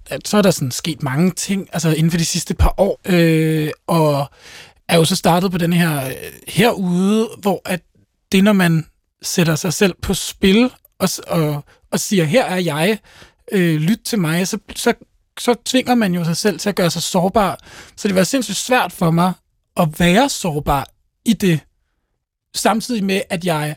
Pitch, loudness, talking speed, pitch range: 180 Hz, -17 LUFS, 190 wpm, 160-205 Hz